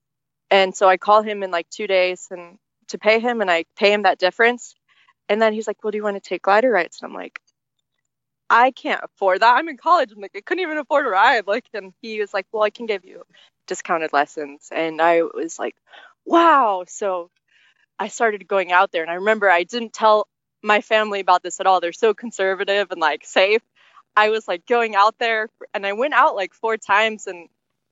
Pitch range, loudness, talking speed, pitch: 185-225 Hz, -19 LUFS, 225 wpm, 205 Hz